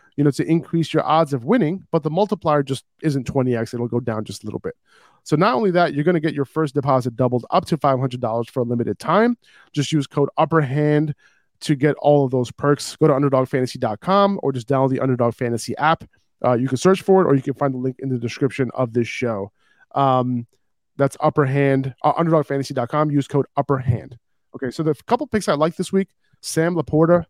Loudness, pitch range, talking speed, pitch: -20 LUFS, 125-160 Hz, 215 wpm, 140 Hz